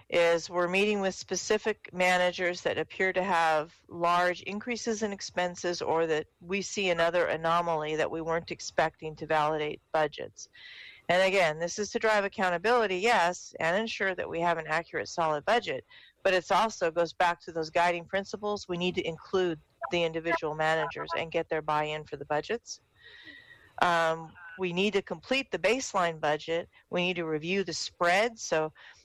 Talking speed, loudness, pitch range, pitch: 170 wpm, -29 LUFS, 160-195 Hz, 175 Hz